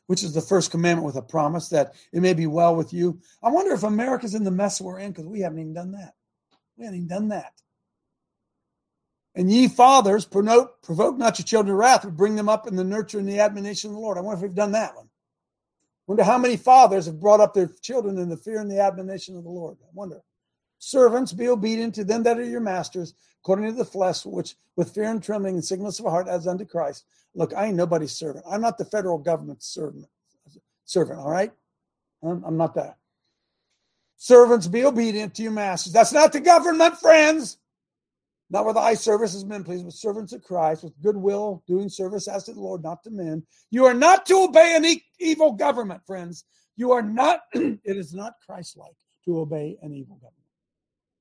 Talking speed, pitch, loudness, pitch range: 215 wpm, 200 Hz, -21 LUFS, 175-225 Hz